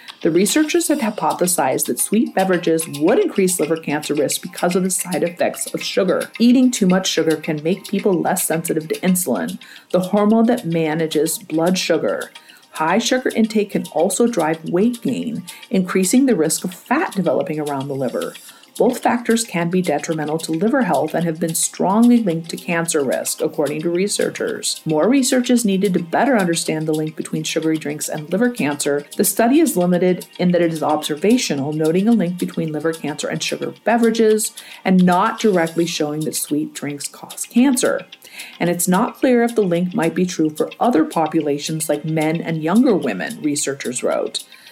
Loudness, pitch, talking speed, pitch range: -18 LUFS, 180 Hz, 180 wpm, 160-225 Hz